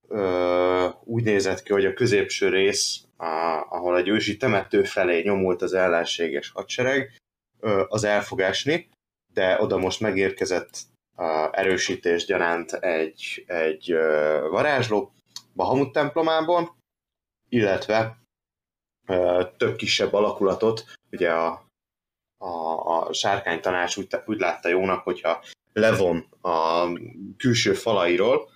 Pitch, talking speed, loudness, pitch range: 95 Hz, 100 wpm, -23 LUFS, 85-120 Hz